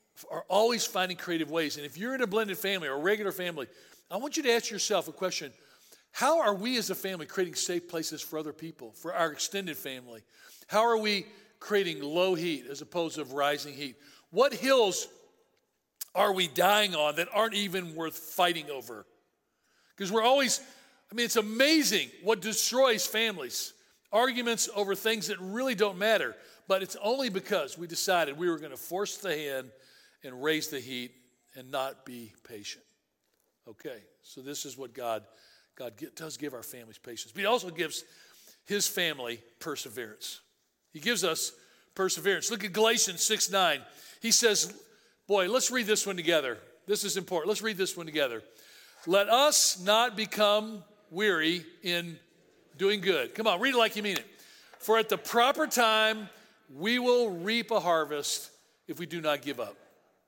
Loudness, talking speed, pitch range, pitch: -29 LUFS, 175 wpm, 160-225 Hz, 195 Hz